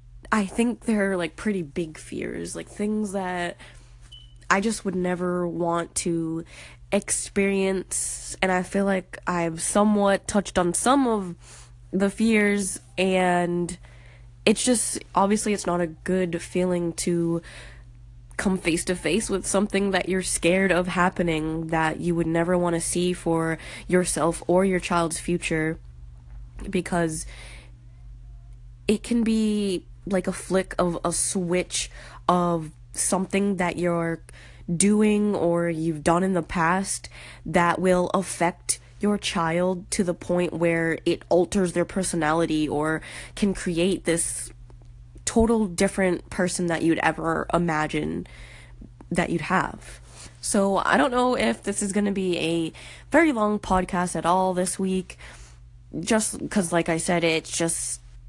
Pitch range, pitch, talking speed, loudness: 155-190 Hz, 175 Hz, 140 wpm, -24 LUFS